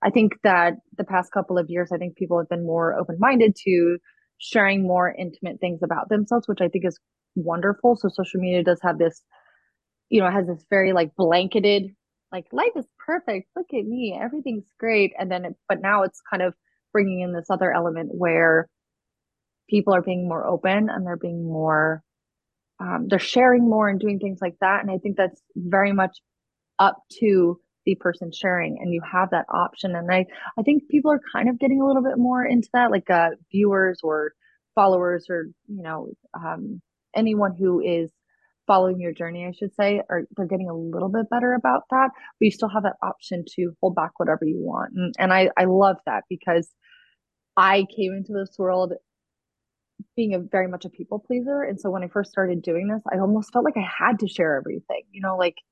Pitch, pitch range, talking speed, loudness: 190 Hz, 175-210 Hz, 205 wpm, -22 LUFS